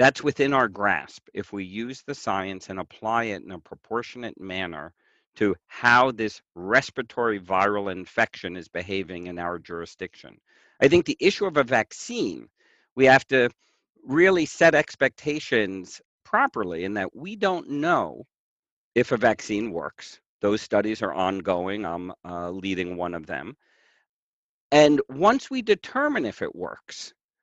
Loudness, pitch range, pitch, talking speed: -24 LUFS, 95-140 Hz, 110 Hz, 145 wpm